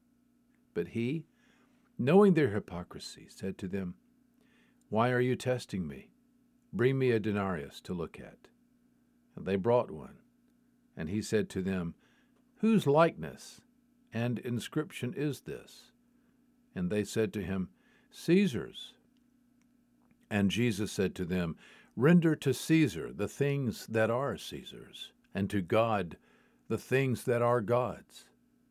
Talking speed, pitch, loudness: 130 wpm, 150 Hz, -32 LUFS